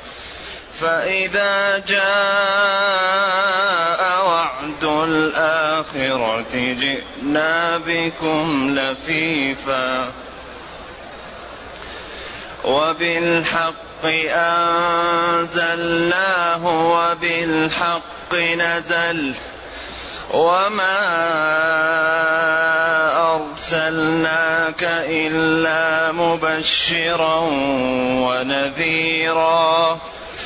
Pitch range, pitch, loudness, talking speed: 160-170 Hz, 165 Hz, -17 LUFS, 30 wpm